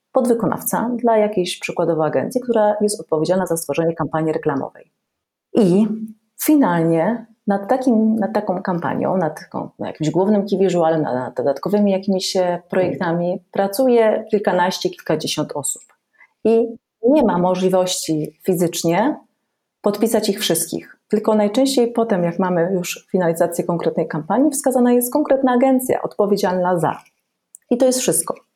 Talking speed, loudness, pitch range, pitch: 130 wpm, -18 LUFS, 175-225 Hz, 195 Hz